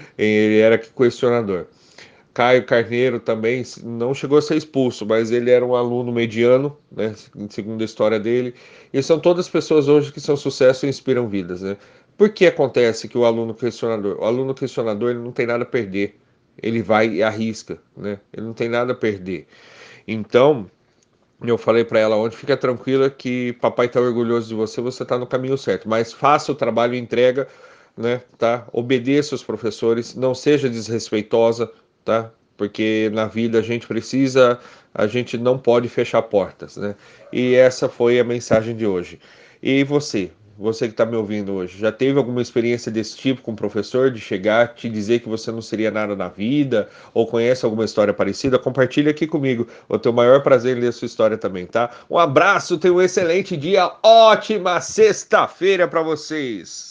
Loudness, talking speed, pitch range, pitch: -19 LUFS, 180 wpm, 110-135 Hz, 120 Hz